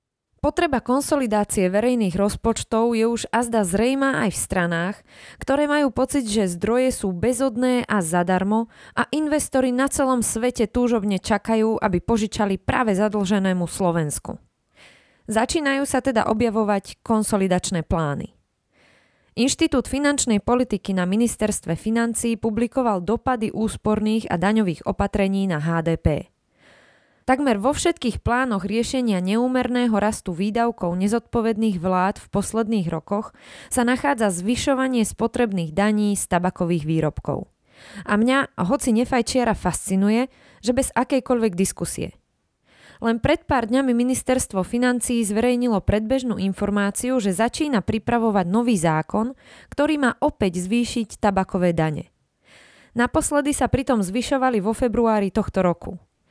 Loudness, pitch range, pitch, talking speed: -21 LUFS, 200-250 Hz, 225 Hz, 115 wpm